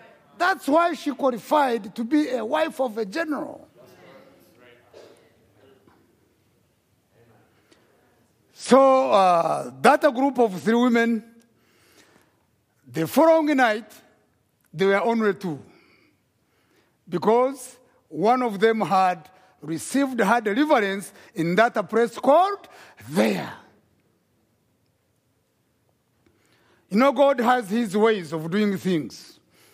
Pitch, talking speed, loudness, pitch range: 230 Hz, 95 wpm, -22 LUFS, 195-275 Hz